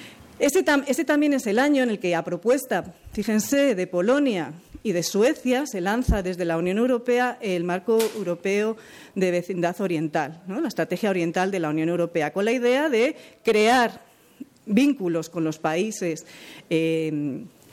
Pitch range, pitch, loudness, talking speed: 170-245 Hz, 195 Hz, -23 LUFS, 160 wpm